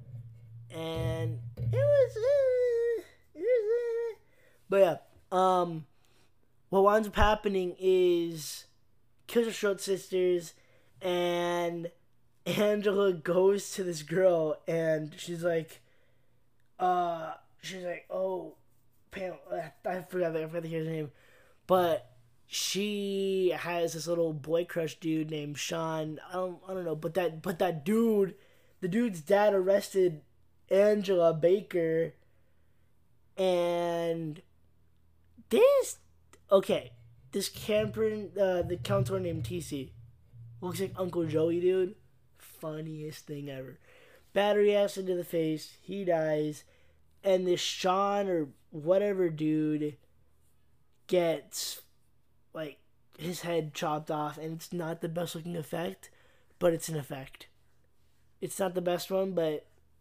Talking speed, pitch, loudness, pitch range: 120 wpm, 170 Hz, -30 LUFS, 130-190 Hz